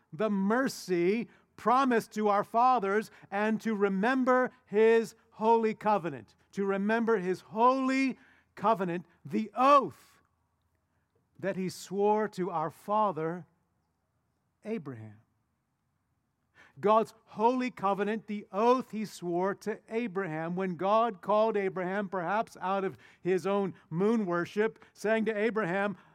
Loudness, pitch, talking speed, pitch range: -30 LUFS, 200 Hz, 110 wpm, 175-220 Hz